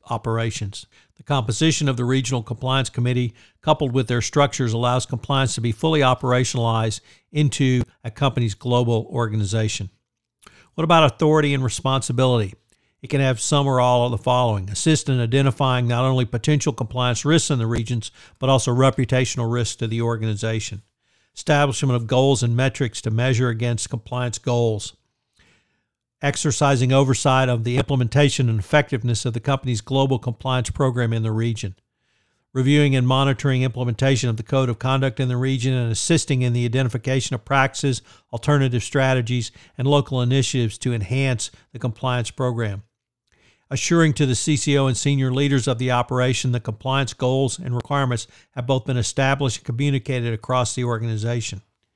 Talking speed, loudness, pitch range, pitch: 155 wpm, -21 LUFS, 115-135 Hz, 125 Hz